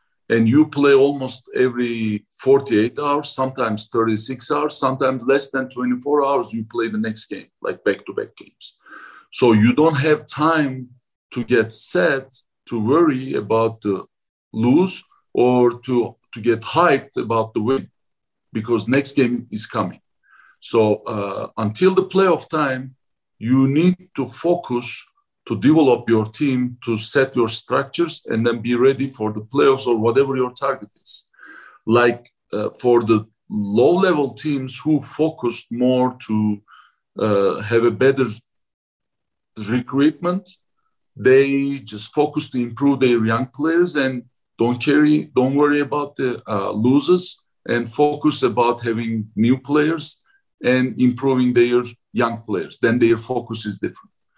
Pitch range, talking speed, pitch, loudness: 115-145 Hz, 145 wpm, 125 Hz, -19 LUFS